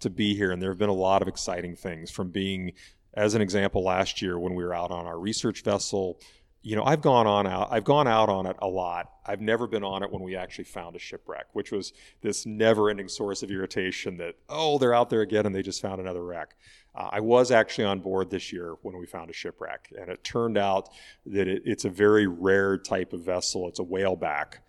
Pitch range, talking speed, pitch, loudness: 95-110 Hz, 245 wpm, 100 Hz, -27 LUFS